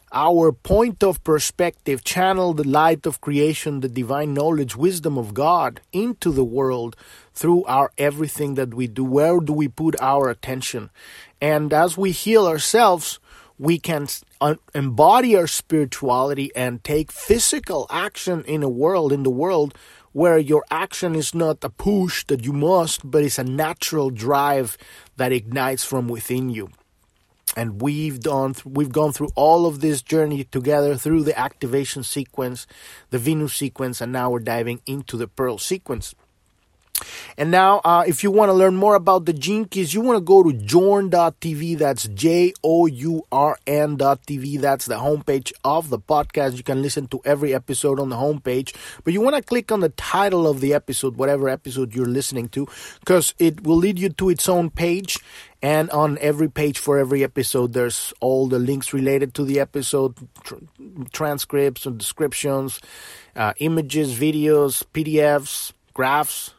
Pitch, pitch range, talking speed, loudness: 145 Hz, 130-165 Hz, 165 wpm, -20 LUFS